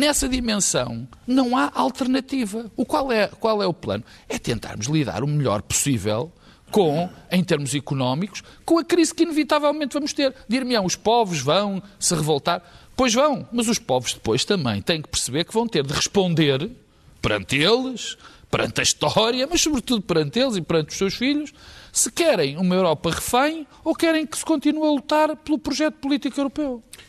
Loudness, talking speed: -22 LUFS, 180 wpm